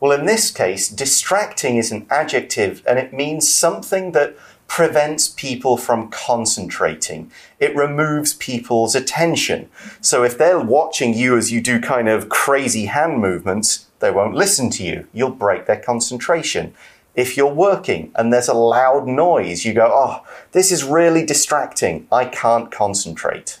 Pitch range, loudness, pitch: 115-150 Hz, -17 LUFS, 125 Hz